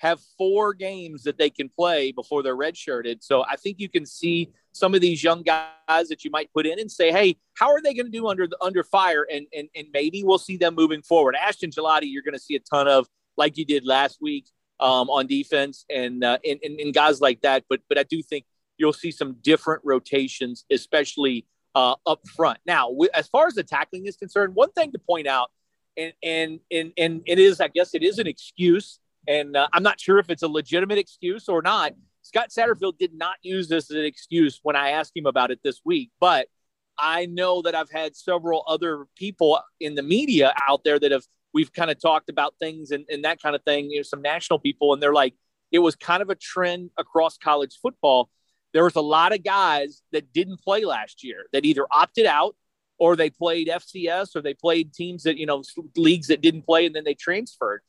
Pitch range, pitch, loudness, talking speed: 150-185 Hz, 165 Hz, -22 LUFS, 225 wpm